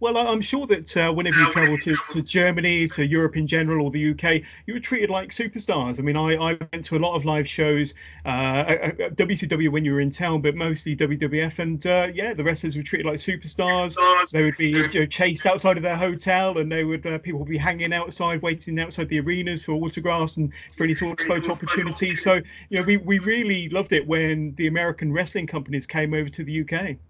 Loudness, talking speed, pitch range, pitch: -22 LUFS, 230 wpm, 155-180 Hz, 165 Hz